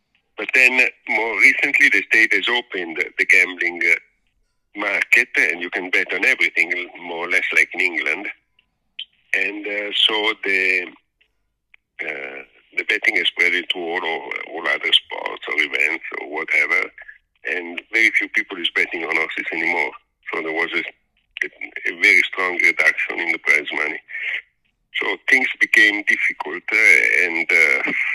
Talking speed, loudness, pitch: 145 wpm, -17 LUFS, 390 Hz